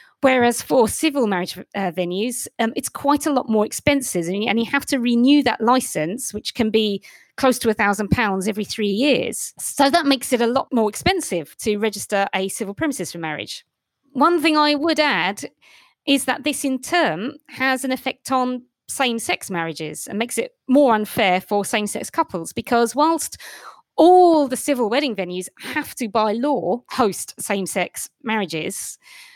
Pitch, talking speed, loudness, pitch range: 240 Hz, 180 wpm, -20 LUFS, 205-280 Hz